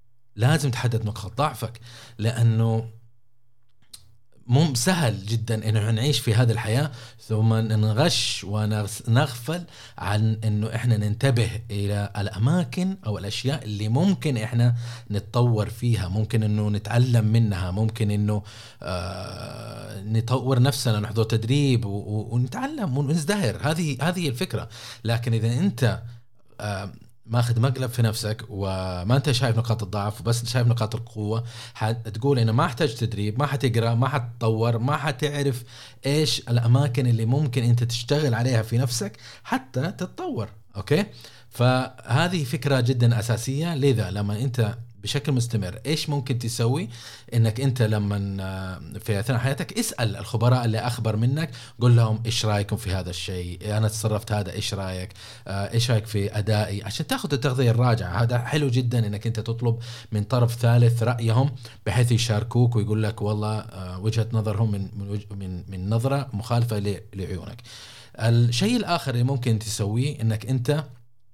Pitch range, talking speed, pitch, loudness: 110-125 Hz, 135 wpm, 115 Hz, -24 LUFS